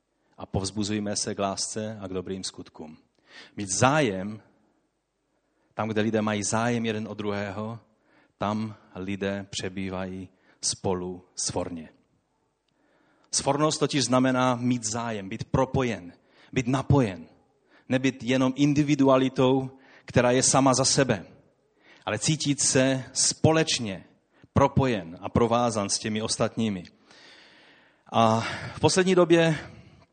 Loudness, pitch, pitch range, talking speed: -25 LUFS, 115 Hz, 100-135 Hz, 110 wpm